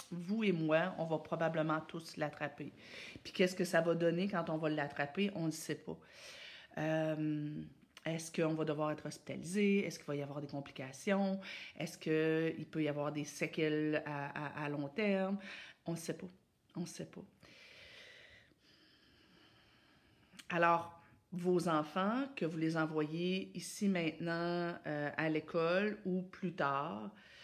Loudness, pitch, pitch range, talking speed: -38 LUFS, 165 Hz, 155-180 Hz, 155 wpm